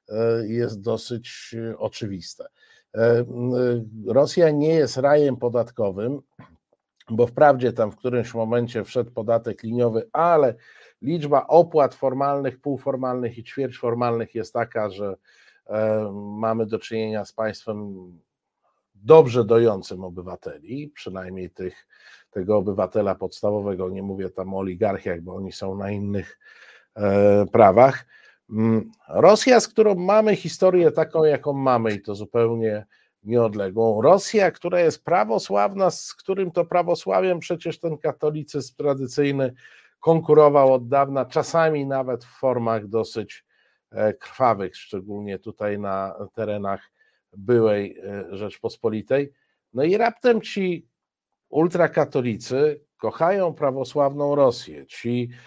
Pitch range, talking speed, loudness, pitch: 105-145 Hz, 105 wpm, -21 LUFS, 120 Hz